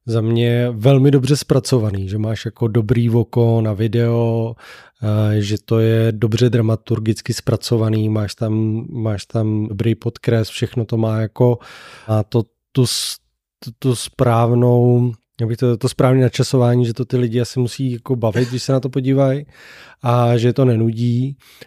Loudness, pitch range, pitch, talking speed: -17 LUFS, 110-125 Hz, 120 Hz, 155 wpm